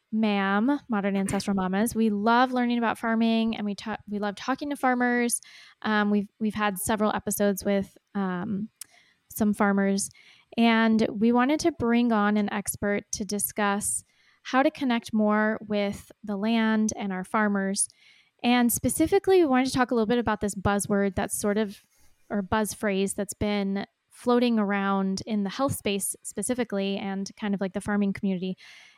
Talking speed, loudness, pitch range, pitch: 170 wpm, -26 LUFS, 200-235 Hz, 210 Hz